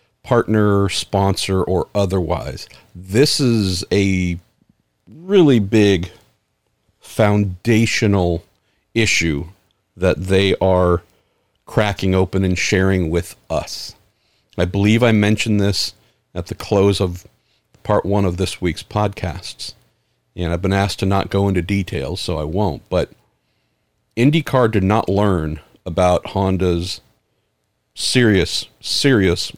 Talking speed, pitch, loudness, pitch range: 115 wpm, 95 Hz, -18 LUFS, 90-105 Hz